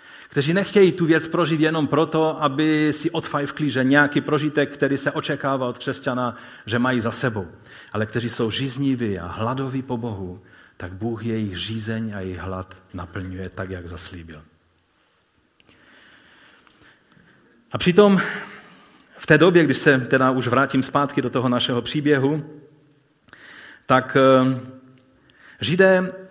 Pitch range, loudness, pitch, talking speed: 115-150 Hz, -21 LUFS, 130 Hz, 130 wpm